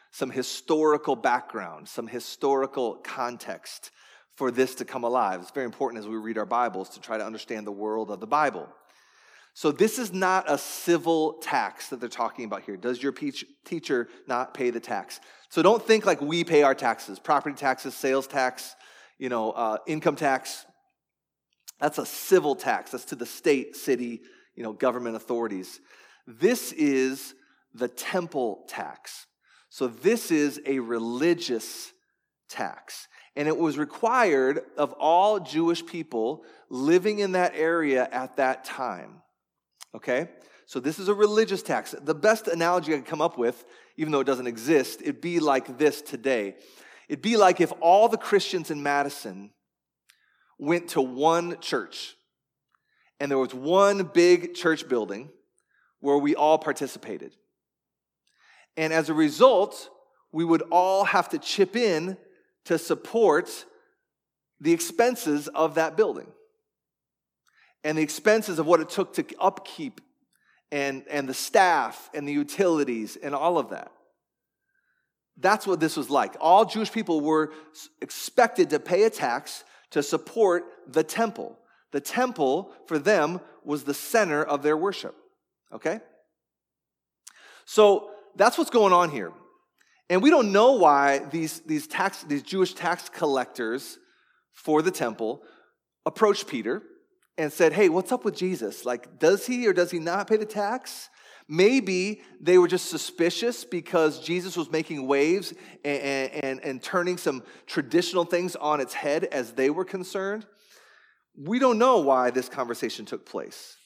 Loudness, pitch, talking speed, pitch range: -25 LUFS, 165 Hz, 155 wpm, 140-210 Hz